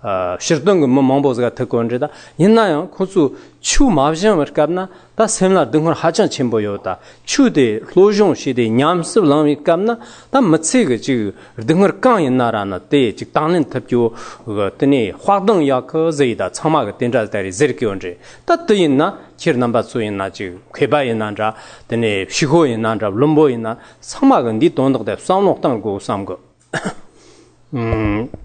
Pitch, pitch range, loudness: 140 Hz, 115-180 Hz, -16 LUFS